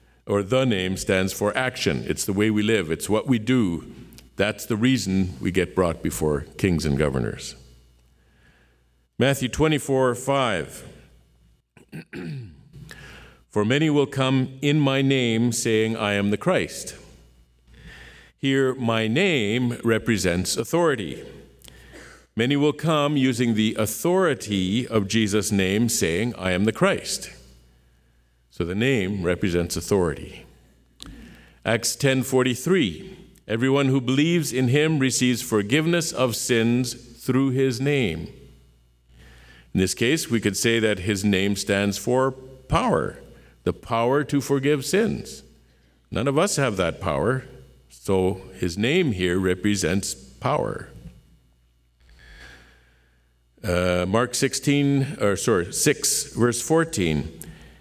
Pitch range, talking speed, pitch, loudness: 80-130 Hz, 120 wpm, 110 Hz, -23 LUFS